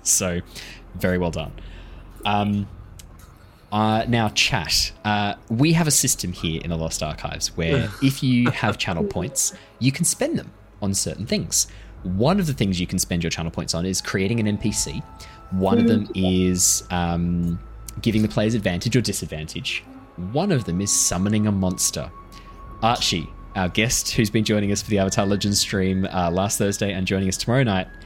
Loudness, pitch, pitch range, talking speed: -22 LUFS, 100 Hz, 90-110 Hz, 180 wpm